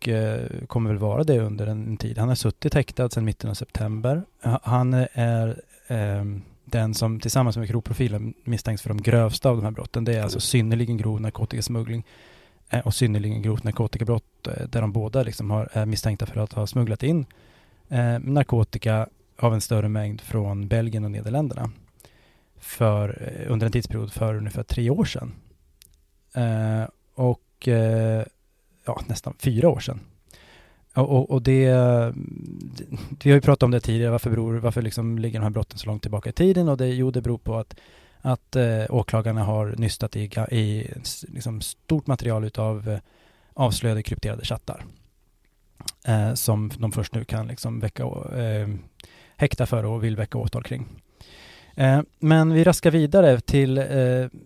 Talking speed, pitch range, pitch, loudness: 165 wpm, 110-125 Hz, 115 Hz, -24 LUFS